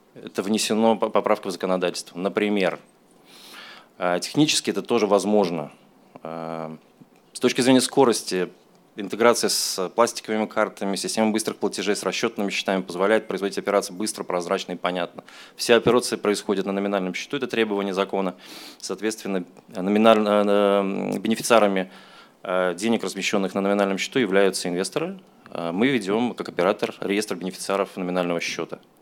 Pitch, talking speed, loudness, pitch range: 100 Hz, 120 wpm, -23 LUFS, 95-110 Hz